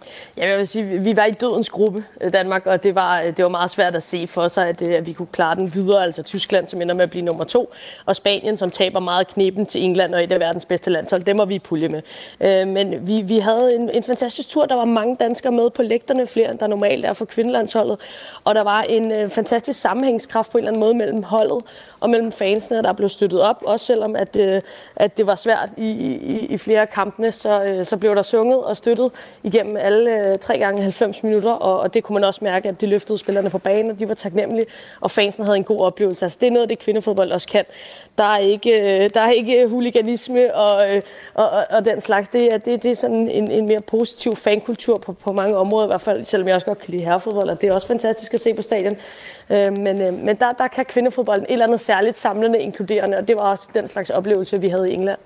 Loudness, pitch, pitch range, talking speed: -19 LUFS, 210 Hz, 195-230 Hz, 250 wpm